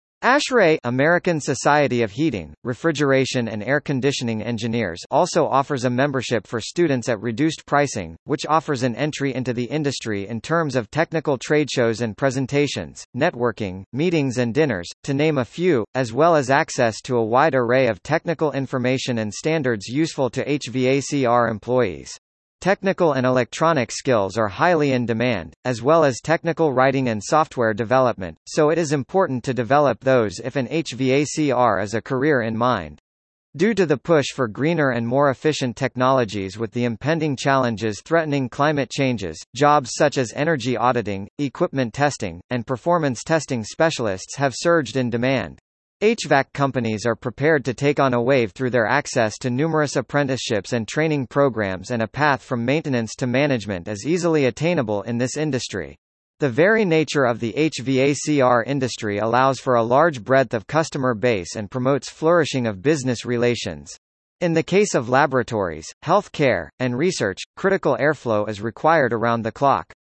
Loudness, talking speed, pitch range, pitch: -21 LUFS, 165 wpm, 120-150 Hz, 130 Hz